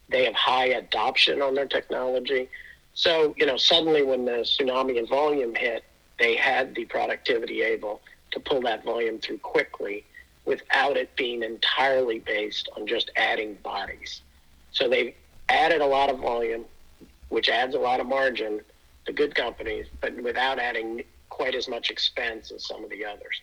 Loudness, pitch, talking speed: -25 LUFS, 170 Hz, 165 wpm